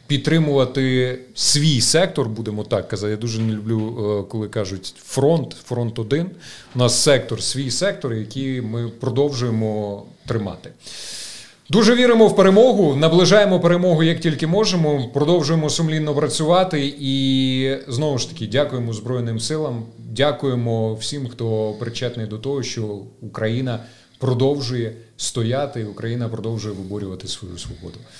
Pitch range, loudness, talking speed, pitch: 115-145 Hz, -19 LUFS, 125 wpm, 125 Hz